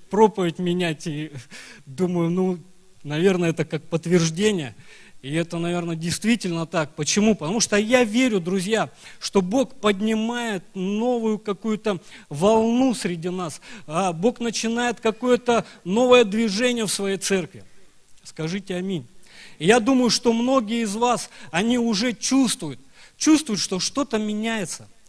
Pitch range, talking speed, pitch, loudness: 175-230 Hz, 125 wpm, 200 Hz, -22 LUFS